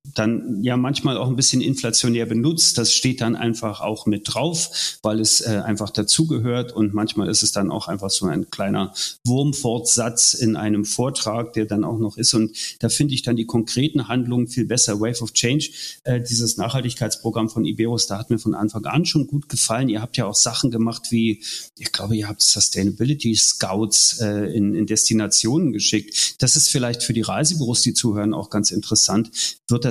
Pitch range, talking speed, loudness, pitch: 110-125 Hz, 195 wpm, -19 LUFS, 115 Hz